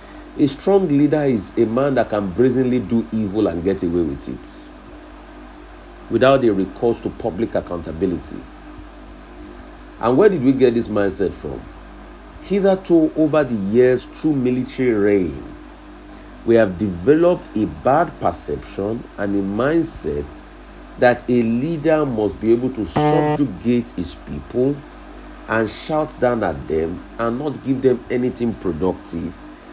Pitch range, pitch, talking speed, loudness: 105-150 Hz, 125 Hz, 135 wpm, -19 LUFS